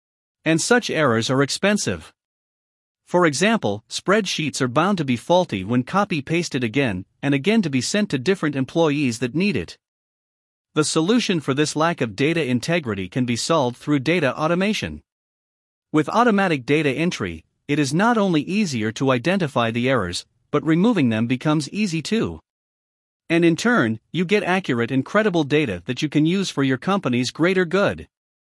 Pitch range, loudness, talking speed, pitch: 125-180 Hz, -21 LUFS, 165 wpm, 155 Hz